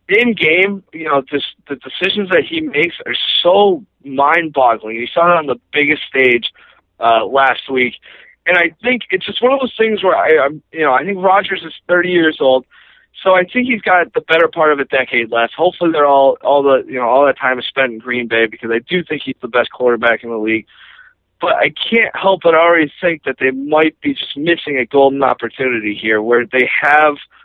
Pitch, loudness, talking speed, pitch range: 150 Hz, -14 LUFS, 225 wpm, 130-180 Hz